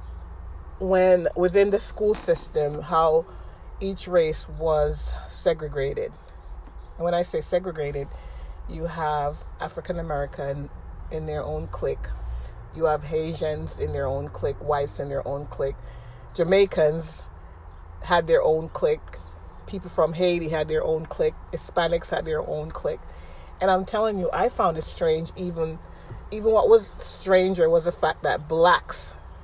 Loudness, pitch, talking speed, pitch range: -25 LUFS, 160 Hz, 145 wpm, 140-190 Hz